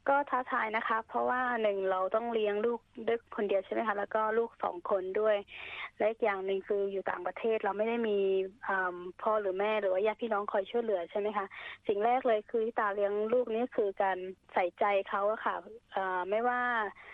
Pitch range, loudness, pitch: 195-230 Hz, -32 LUFS, 215 Hz